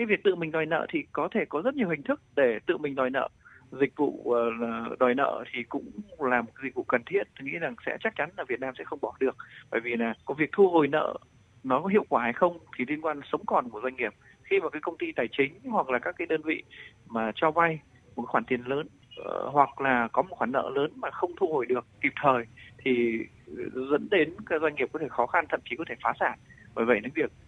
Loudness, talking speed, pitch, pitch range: -28 LUFS, 260 wpm, 155 Hz, 125-210 Hz